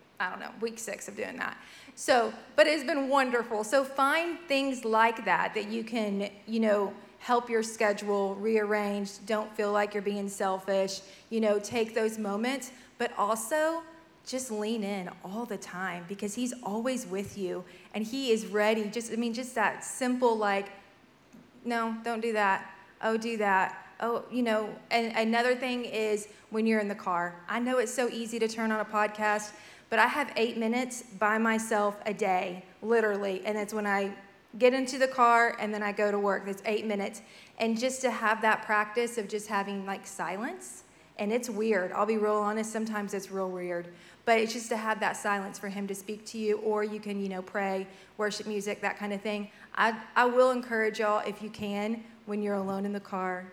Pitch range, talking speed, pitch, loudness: 200-230 Hz, 200 wpm, 215 Hz, -30 LUFS